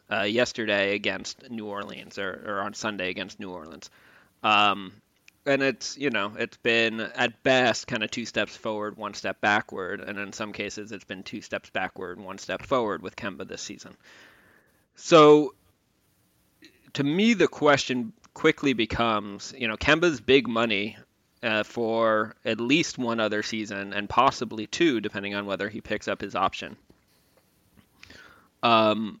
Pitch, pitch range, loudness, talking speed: 110 Hz, 105-125 Hz, -25 LUFS, 160 wpm